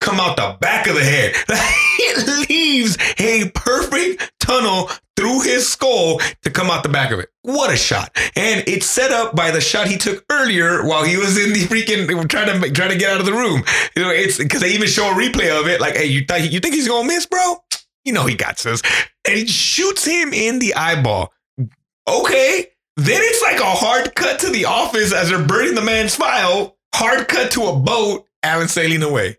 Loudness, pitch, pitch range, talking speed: -15 LUFS, 205 Hz, 165-250 Hz, 220 wpm